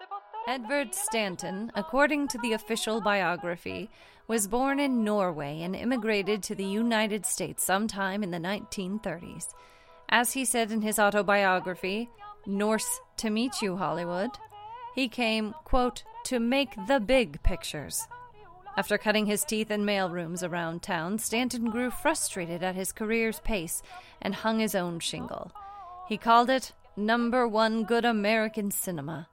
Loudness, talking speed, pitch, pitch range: -29 LUFS, 140 wpm, 220 Hz, 195-250 Hz